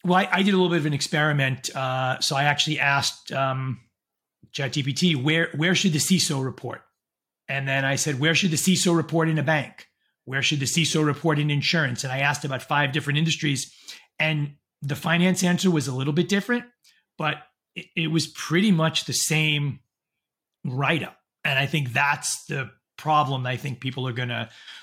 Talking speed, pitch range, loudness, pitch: 190 wpm, 135-165 Hz, -23 LUFS, 150 Hz